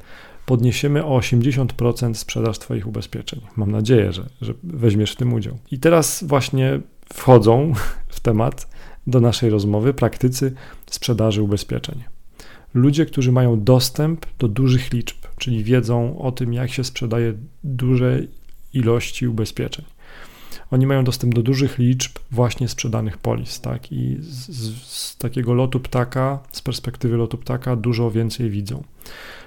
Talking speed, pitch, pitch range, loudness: 135 wpm, 125 Hz, 115-130 Hz, -20 LUFS